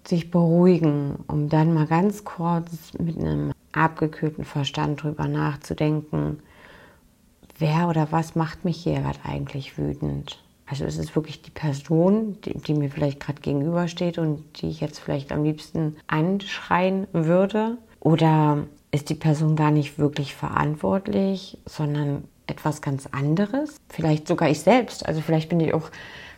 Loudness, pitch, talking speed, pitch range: -24 LUFS, 155 Hz, 145 wpm, 145-170 Hz